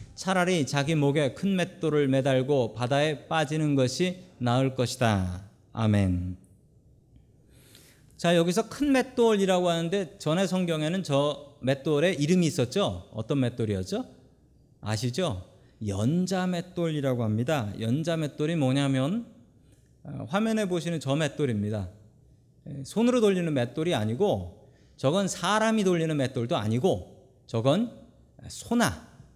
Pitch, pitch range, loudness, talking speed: 145 Hz, 125-175 Hz, -27 LUFS, 260 characters per minute